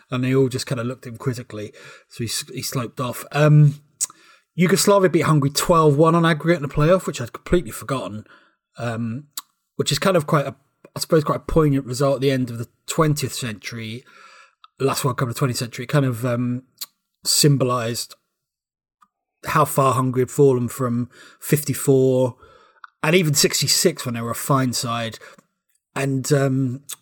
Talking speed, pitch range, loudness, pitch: 170 wpm, 125-150 Hz, -20 LUFS, 135 Hz